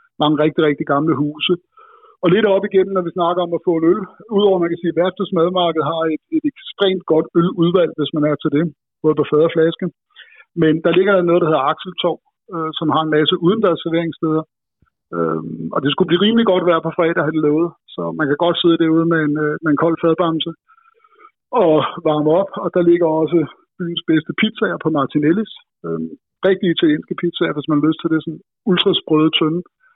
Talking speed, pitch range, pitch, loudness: 210 wpm, 155-185 Hz, 165 Hz, -17 LUFS